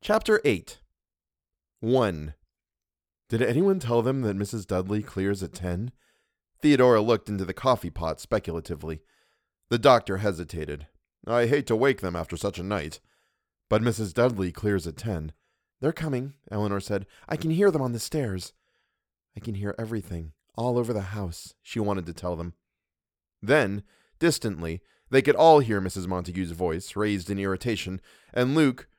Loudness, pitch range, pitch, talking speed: -26 LUFS, 85-120 Hz, 100 Hz, 155 wpm